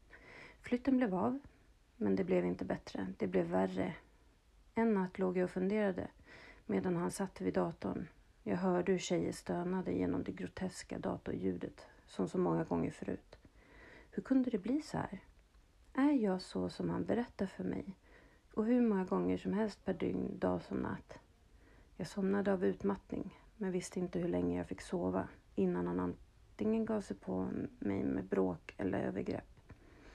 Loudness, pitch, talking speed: -37 LUFS, 180 Hz, 165 wpm